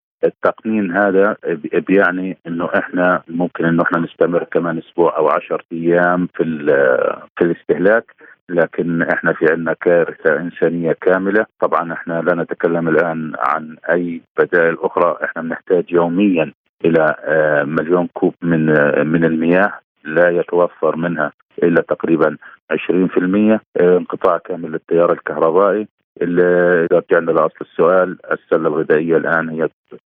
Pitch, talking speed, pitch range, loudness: 90 Hz, 120 wpm, 85-100 Hz, -16 LUFS